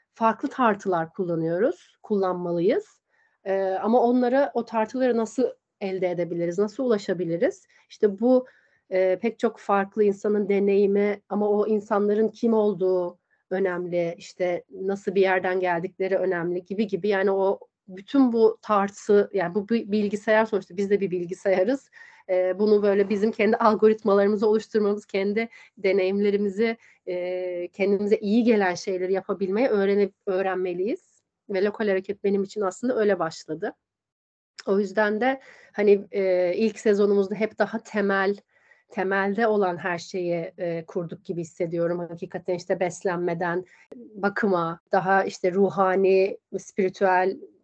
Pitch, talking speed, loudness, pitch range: 200 Hz, 125 wpm, -24 LUFS, 185-215 Hz